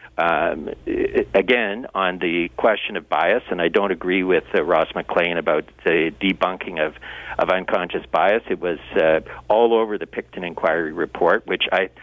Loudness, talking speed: -21 LUFS, 170 wpm